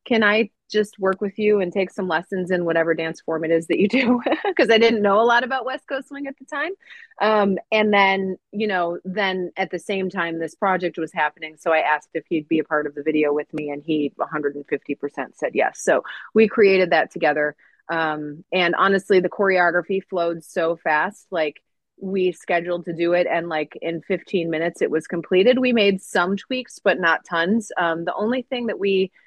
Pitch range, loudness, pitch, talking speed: 165-210 Hz, -21 LUFS, 180 Hz, 220 wpm